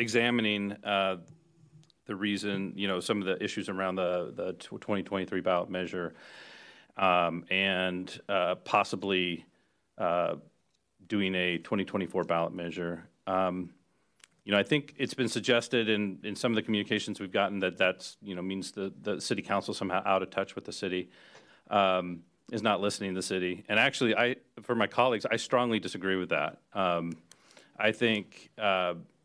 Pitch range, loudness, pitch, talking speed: 90-105 Hz, -30 LUFS, 95 Hz, 165 wpm